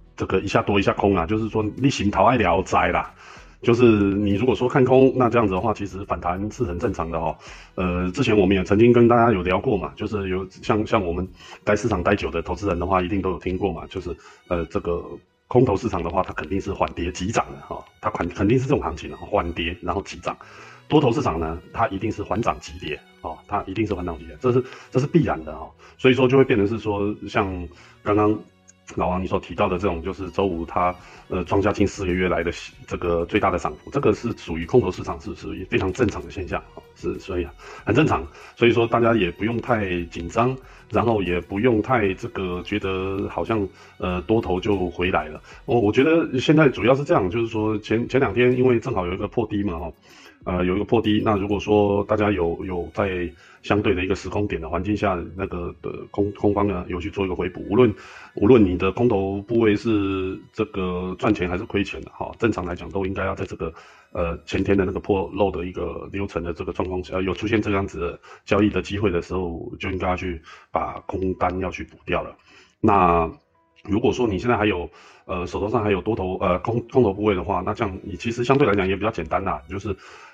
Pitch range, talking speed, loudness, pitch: 90-110 Hz, 335 characters per minute, -22 LUFS, 100 Hz